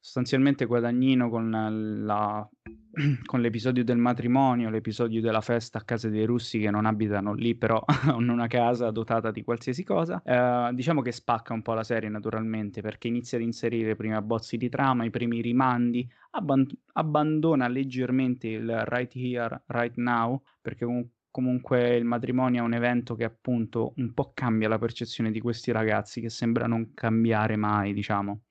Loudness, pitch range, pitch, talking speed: -27 LUFS, 110-125 Hz, 120 Hz, 165 wpm